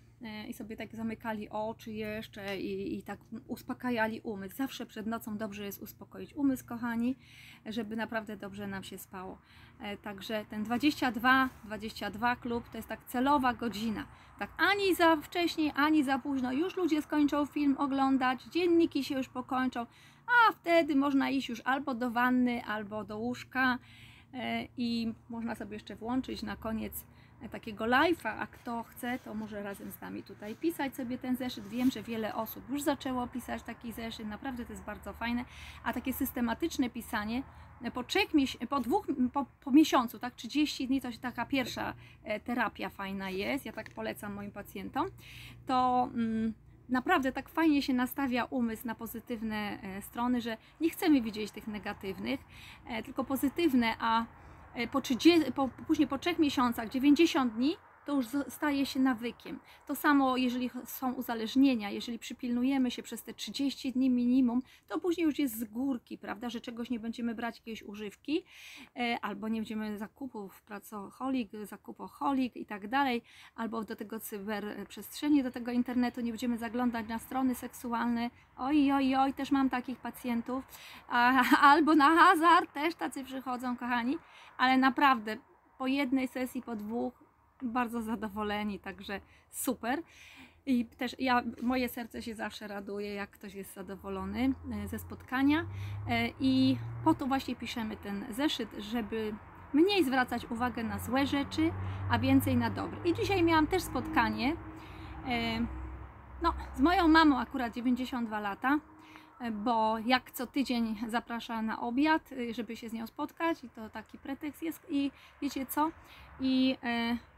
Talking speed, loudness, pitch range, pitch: 150 wpm, -32 LUFS, 225-275 Hz, 245 Hz